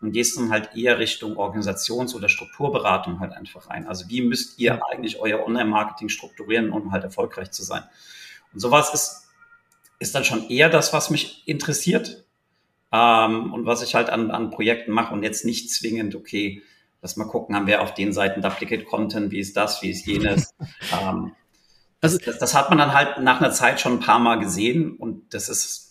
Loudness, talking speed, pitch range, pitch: -22 LUFS, 195 wpm, 105-140 Hz, 115 Hz